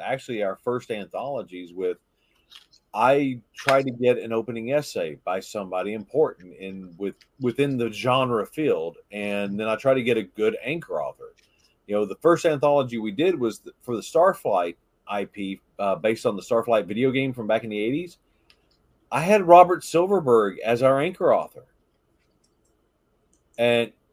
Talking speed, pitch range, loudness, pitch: 160 wpm, 105-140 Hz, -23 LUFS, 120 Hz